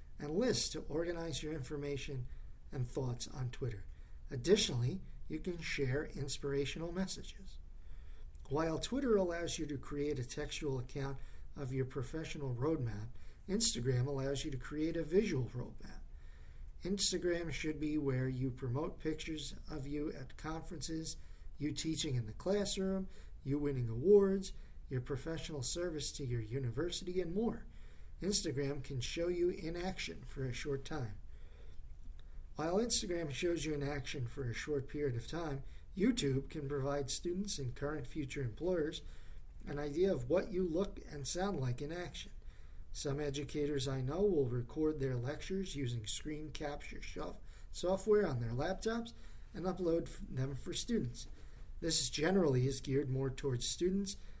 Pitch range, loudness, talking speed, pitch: 130-165 Hz, -38 LUFS, 145 wpm, 145 Hz